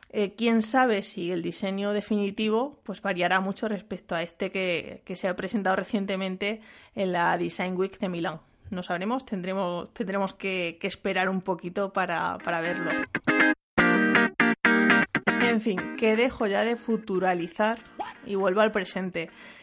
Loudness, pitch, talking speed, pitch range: -26 LUFS, 195 Hz, 145 wpm, 185-215 Hz